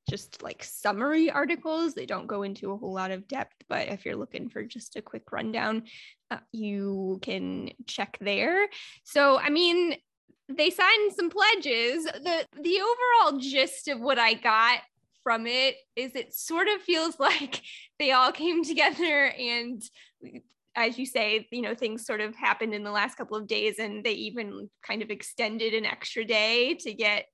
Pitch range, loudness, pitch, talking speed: 220-315 Hz, -26 LUFS, 250 Hz, 180 wpm